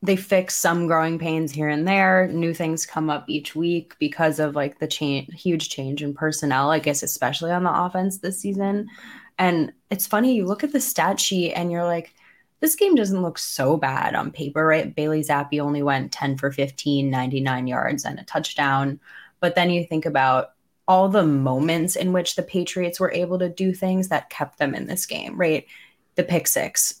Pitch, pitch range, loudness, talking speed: 165 Hz, 150-185 Hz, -22 LUFS, 200 wpm